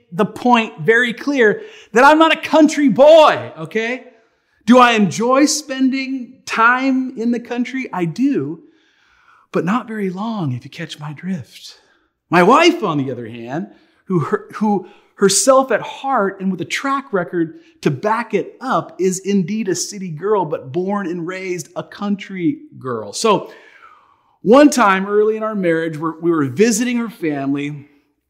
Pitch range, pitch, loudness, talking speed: 175-260 Hz, 210 Hz, -16 LUFS, 160 wpm